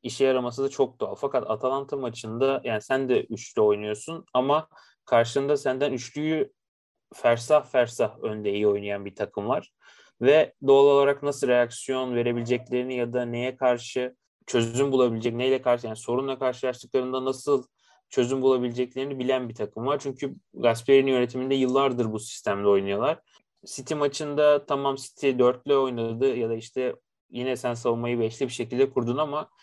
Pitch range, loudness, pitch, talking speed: 120-135 Hz, -25 LUFS, 130 Hz, 150 wpm